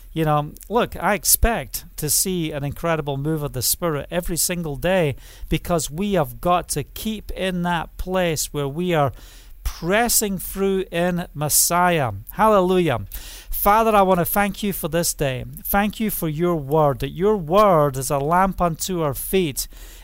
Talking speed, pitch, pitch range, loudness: 170 wpm, 170 Hz, 145-190 Hz, -21 LUFS